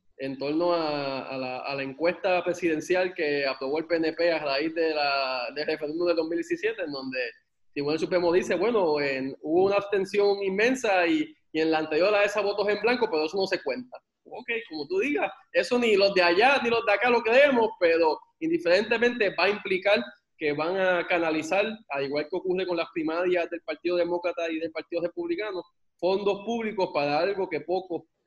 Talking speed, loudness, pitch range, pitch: 195 wpm, -26 LUFS, 155-205 Hz, 175 Hz